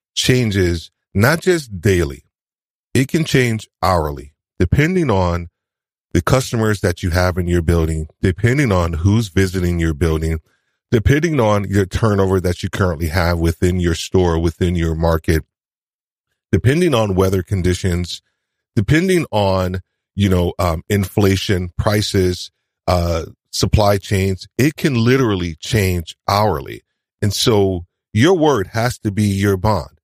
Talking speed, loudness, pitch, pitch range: 130 wpm, -17 LUFS, 95 Hz, 90-110 Hz